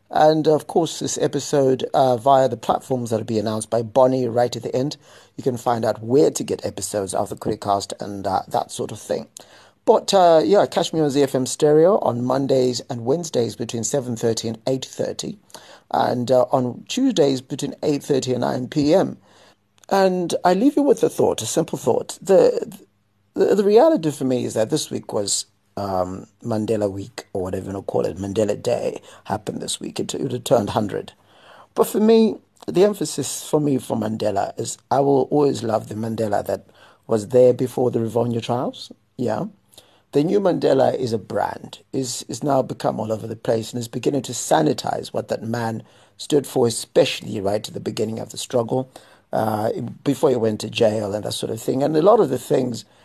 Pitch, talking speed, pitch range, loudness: 125 Hz, 200 wpm, 110-145 Hz, -21 LUFS